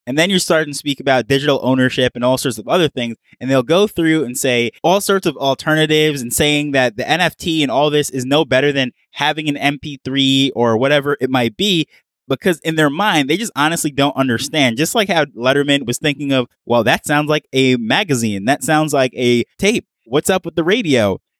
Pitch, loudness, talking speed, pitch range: 140 Hz, -16 LUFS, 215 wpm, 130-155 Hz